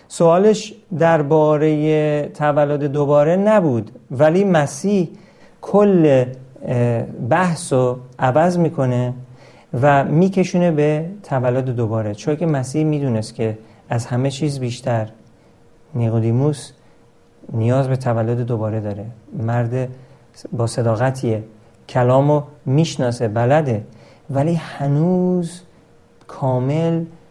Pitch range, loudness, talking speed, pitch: 120-155 Hz, -18 LUFS, 90 wpm, 135 Hz